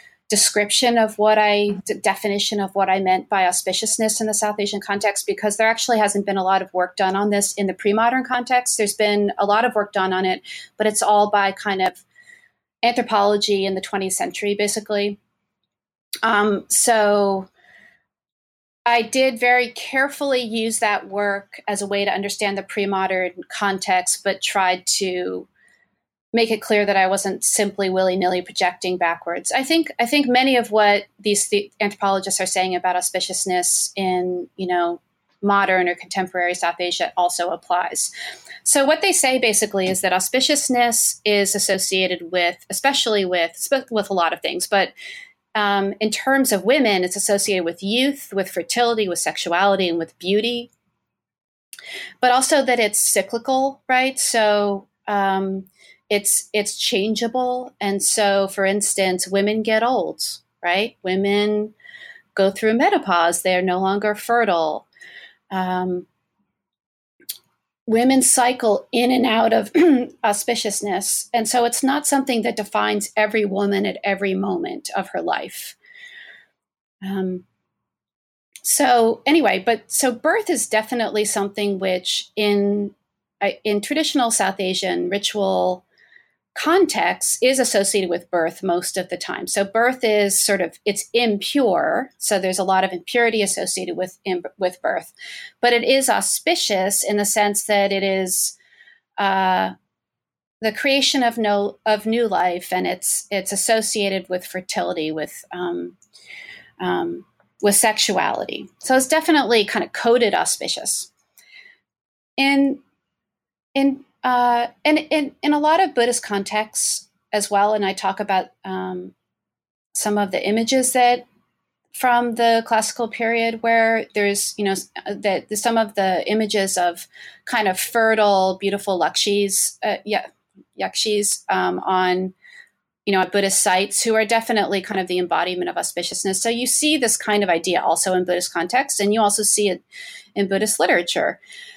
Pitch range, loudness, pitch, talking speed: 190-235 Hz, -19 LUFS, 205 Hz, 150 wpm